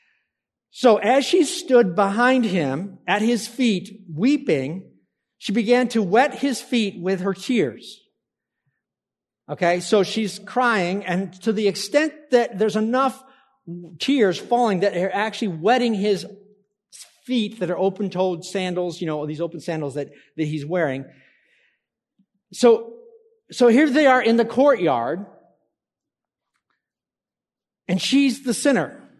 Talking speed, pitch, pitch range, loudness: 130 wpm, 210 Hz, 185-245 Hz, -21 LUFS